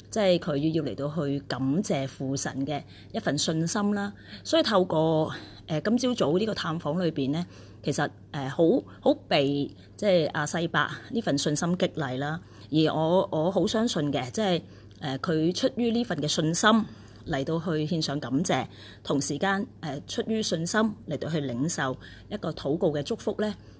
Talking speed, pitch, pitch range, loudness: 240 characters per minute, 160 Hz, 145-190 Hz, -27 LUFS